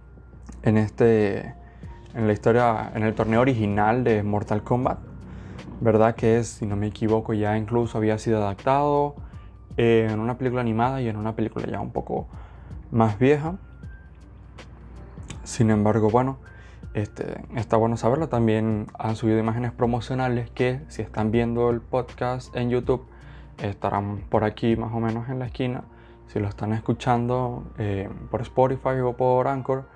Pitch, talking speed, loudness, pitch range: 115 Hz, 155 wpm, -24 LUFS, 105-125 Hz